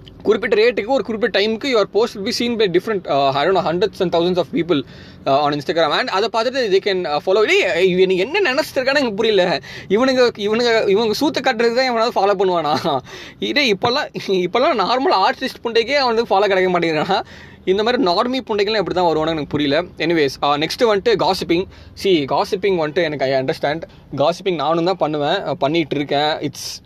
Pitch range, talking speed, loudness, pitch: 170-240 Hz, 170 wpm, -17 LUFS, 195 Hz